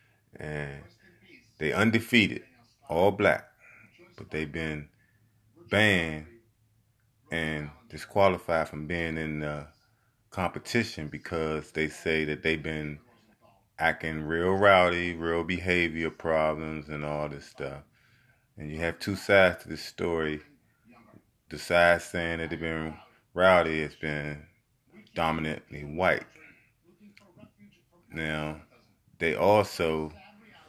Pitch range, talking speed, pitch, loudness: 75-100 Hz, 105 wpm, 80 Hz, -28 LUFS